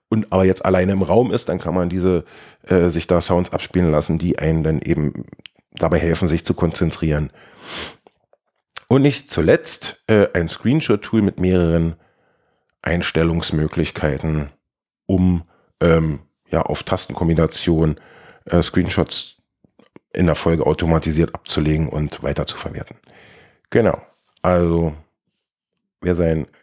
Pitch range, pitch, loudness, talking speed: 80-90 Hz, 85 Hz, -19 LUFS, 120 wpm